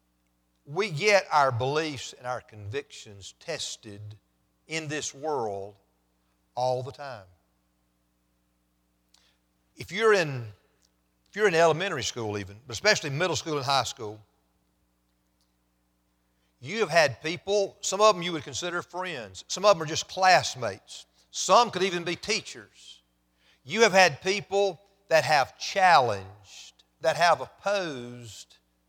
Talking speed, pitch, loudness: 130 wpm, 115 Hz, -26 LUFS